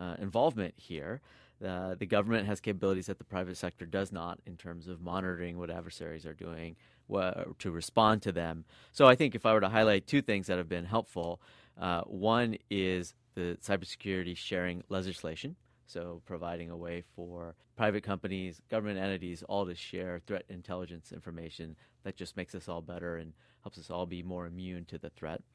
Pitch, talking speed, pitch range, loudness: 90 Hz, 185 wpm, 85-100 Hz, -34 LUFS